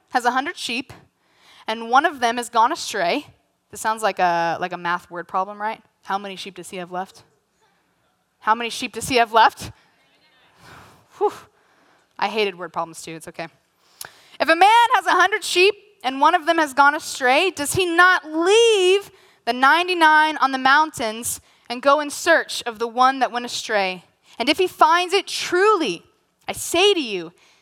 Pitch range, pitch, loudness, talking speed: 210-345 Hz, 255 Hz, -19 LUFS, 190 wpm